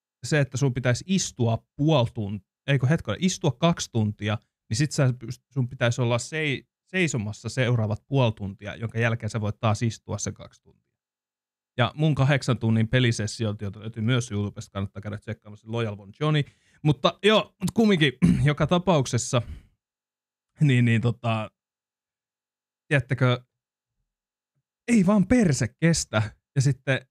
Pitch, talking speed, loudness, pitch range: 120 Hz, 135 wpm, -25 LUFS, 110-145 Hz